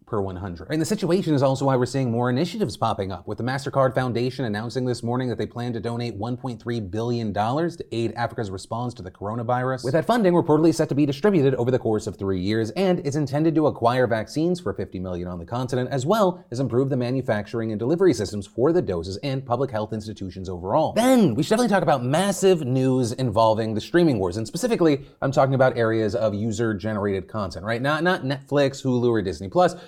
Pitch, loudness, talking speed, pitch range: 125 Hz, -23 LUFS, 215 wpm, 110-150 Hz